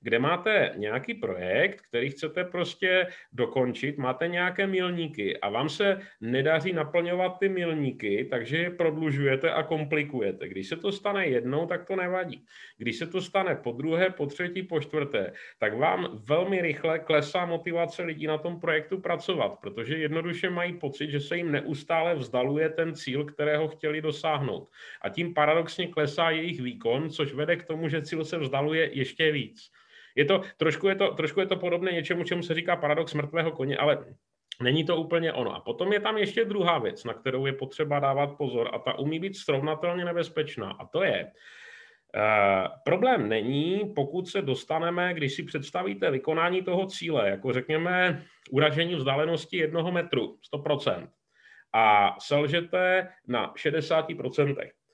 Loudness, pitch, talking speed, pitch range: -28 LUFS, 160 Hz, 160 wpm, 145-175 Hz